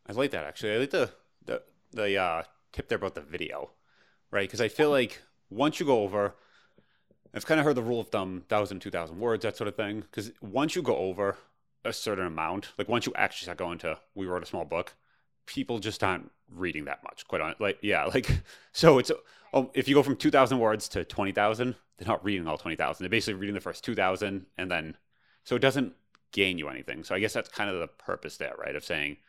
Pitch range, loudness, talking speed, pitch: 95-130 Hz, -29 LUFS, 230 wpm, 105 Hz